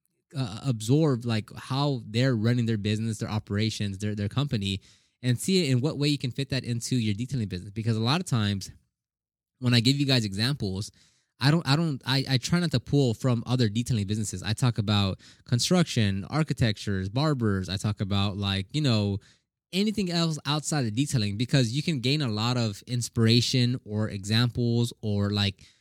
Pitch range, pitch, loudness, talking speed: 105-135 Hz, 120 Hz, -27 LUFS, 190 wpm